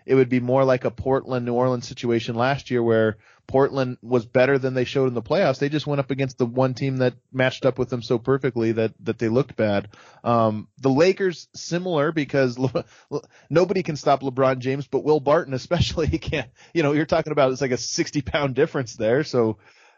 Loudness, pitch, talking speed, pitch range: -22 LUFS, 130 Hz, 215 wpm, 125-140 Hz